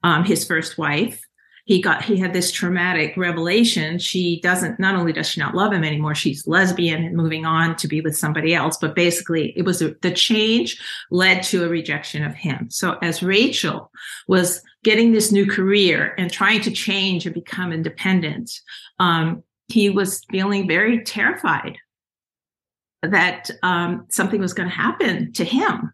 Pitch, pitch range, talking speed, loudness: 180 Hz, 165-195 Hz, 170 wpm, -19 LUFS